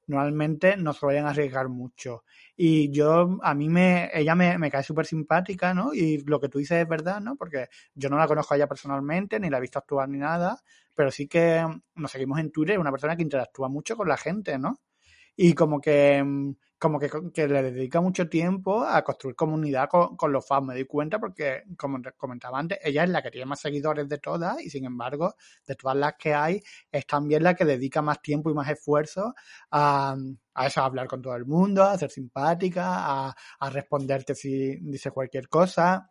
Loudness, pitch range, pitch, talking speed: -26 LUFS, 140-170 Hz, 150 Hz, 215 wpm